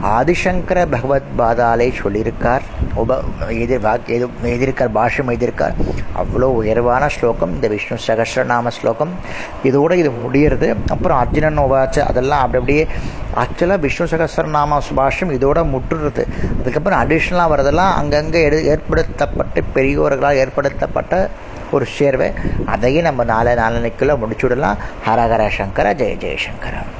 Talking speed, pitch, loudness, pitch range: 115 wpm, 135 Hz, -16 LUFS, 120-150 Hz